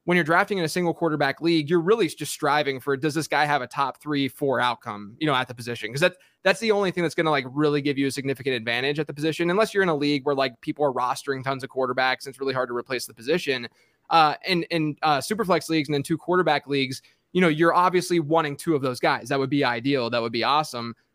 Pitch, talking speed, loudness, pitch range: 145 Hz, 270 wpm, -24 LUFS, 135-165 Hz